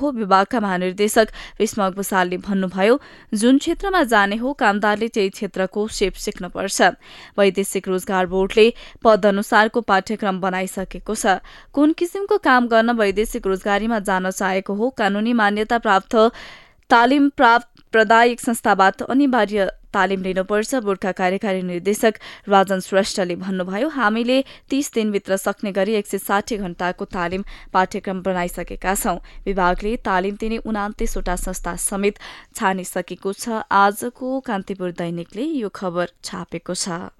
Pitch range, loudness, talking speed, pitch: 190-230 Hz, -20 LUFS, 125 wpm, 205 Hz